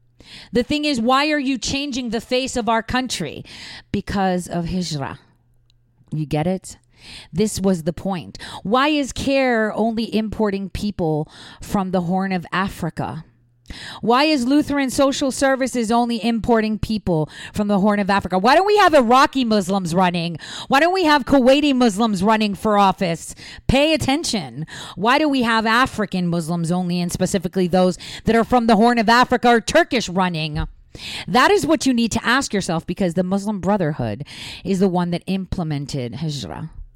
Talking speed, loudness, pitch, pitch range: 165 wpm, -19 LUFS, 205 Hz, 175-250 Hz